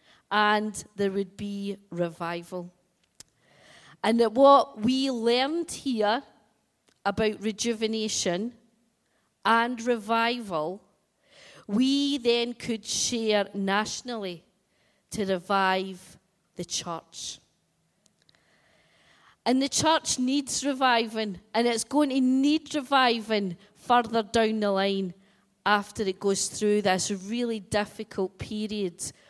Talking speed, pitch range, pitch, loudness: 95 wpm, 195-235 Hz, 215 Hz, -26 LUFS